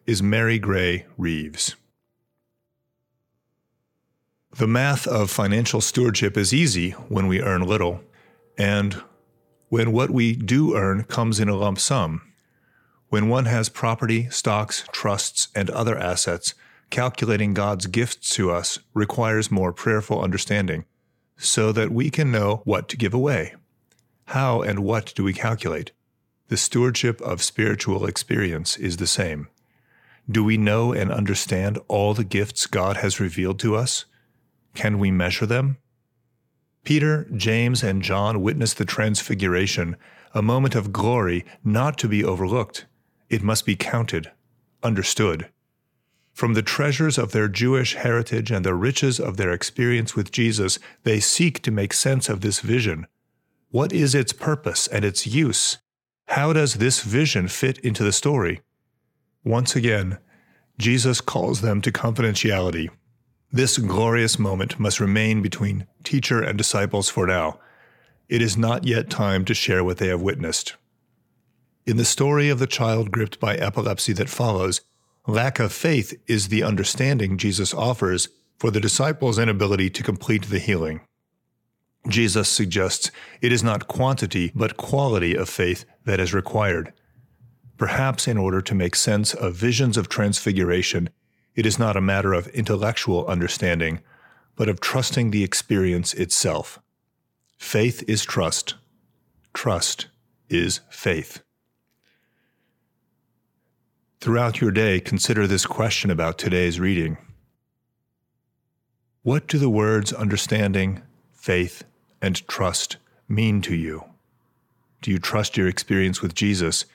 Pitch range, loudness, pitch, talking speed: 100-120 Hz, -22 LUFS, 110 Hz, 140 wpm